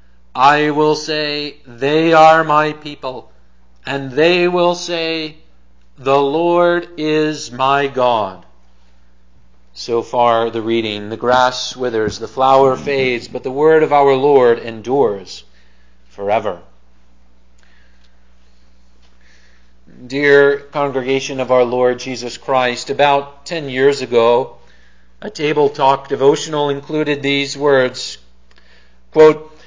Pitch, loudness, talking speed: 130 Hz, -15 LUFS, 105 wpm